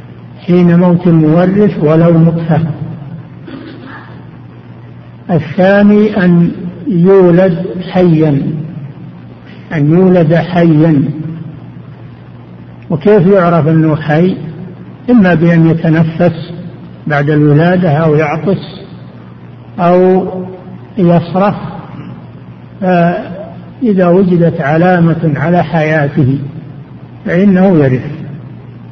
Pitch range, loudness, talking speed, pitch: 150-180 Hz, -9 LUFS, 65 wpm, 165 Hz